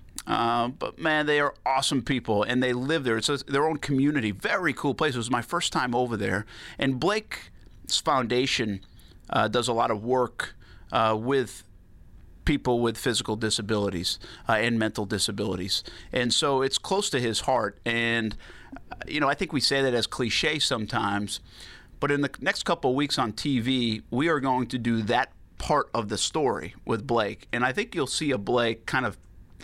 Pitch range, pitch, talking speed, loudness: 105-135 Hz, 120 Hz, 190 wpm, -26 LUFS